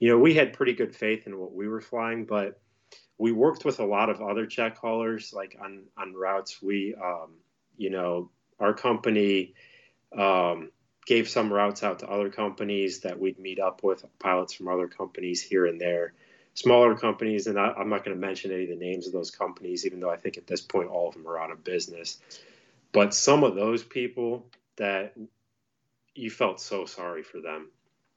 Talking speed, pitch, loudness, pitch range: 200 wpm, 105 Hz, -27 LUFS, 95-115 Hz